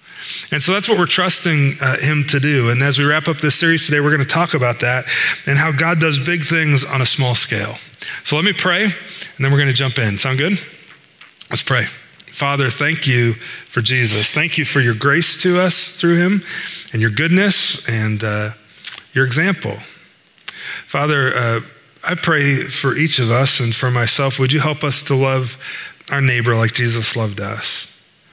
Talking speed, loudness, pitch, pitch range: 195 wpm, -15 LUFS, 140 Hz, 125-160 Hz